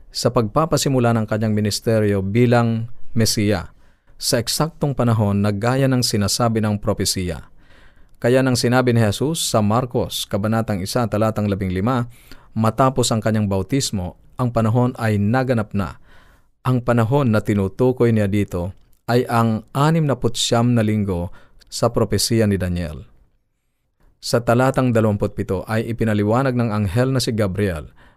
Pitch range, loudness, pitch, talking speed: 105-125 Hz, -19 LUFS, 115 Hz, 135 wpm